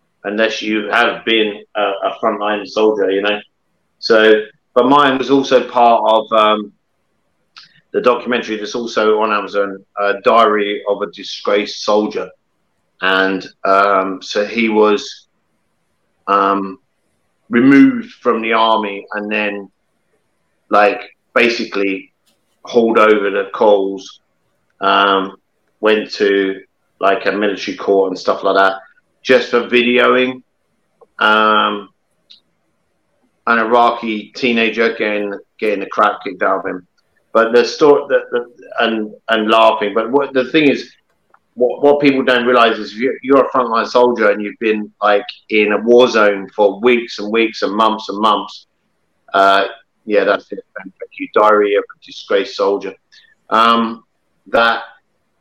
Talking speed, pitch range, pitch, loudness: 140 wpm, 100-125 Hz, 110 Hz, -14 LUFS